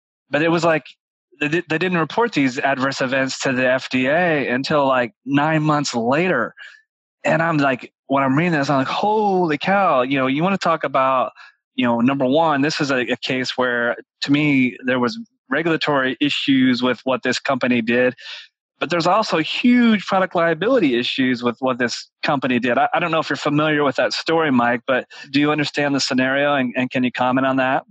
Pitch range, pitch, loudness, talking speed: 130-165 Hz, 140 Hz, -19 LUFS, 200 wpm